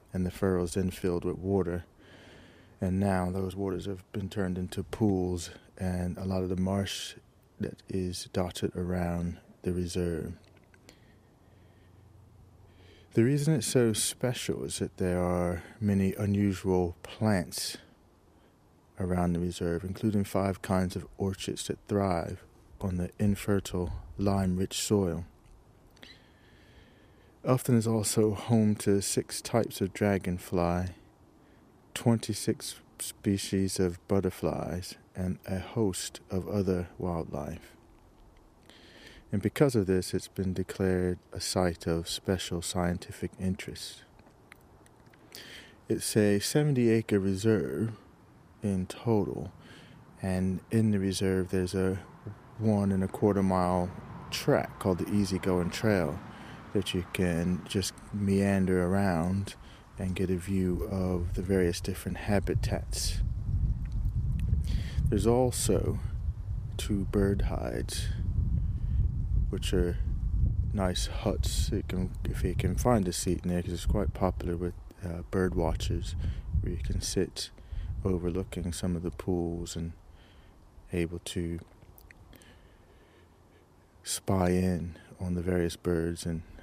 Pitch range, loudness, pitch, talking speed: 90-100 Hz, -31 LUFS, 95 Hz, 120 wpm